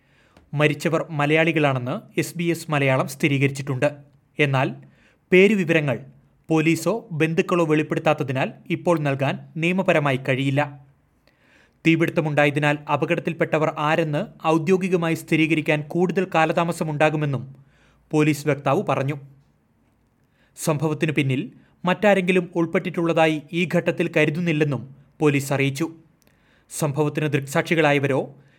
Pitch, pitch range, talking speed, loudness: 155 Hz, 140-165 Hz, 80 wpm, -22 LUFS